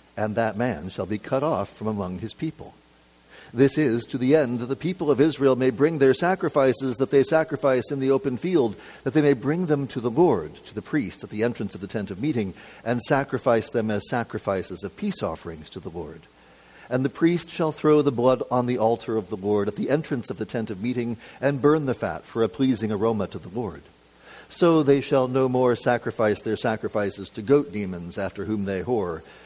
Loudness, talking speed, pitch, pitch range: -24 LUFS, 220 wpm, 125 Hz, 105-140 Hz